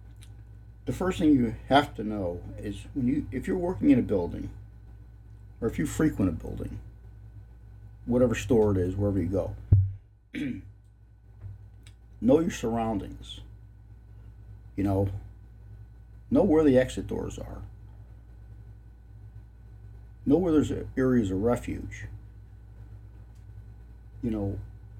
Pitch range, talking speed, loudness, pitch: 105-110 Hz, 115 wpm, -27 LUFS, 105 Hz